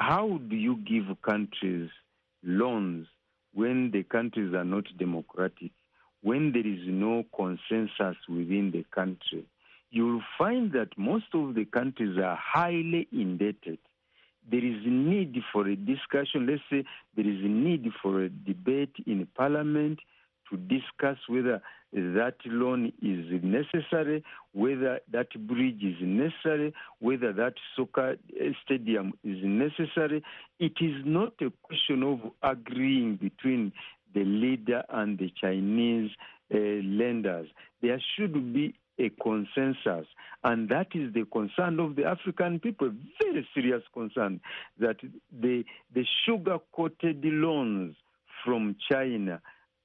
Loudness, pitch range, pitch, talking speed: -30 LUFS, 100-155 Hz, 125 Hz, 130 wpm